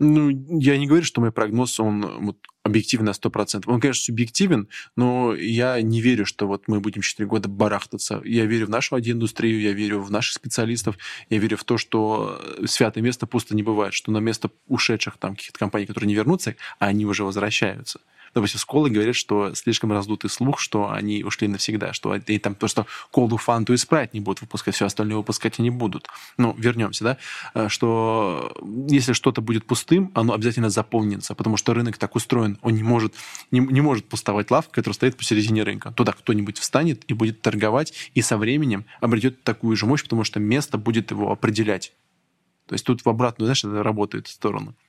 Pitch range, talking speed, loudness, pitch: 105-120 Hz, 195 wpm, -22 LUFS, 110 Hz